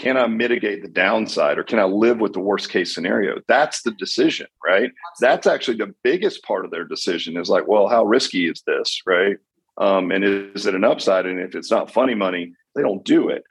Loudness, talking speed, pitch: -20 LUFS, 220 wpm, 115 Hz